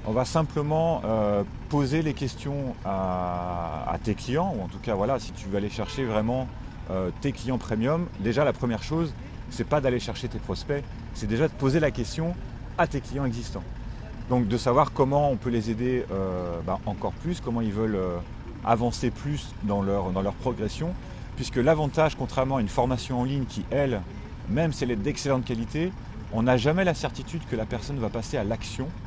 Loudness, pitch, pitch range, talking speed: -27 LUFS, 120 Hz, 110-140 Hz, 200 wpm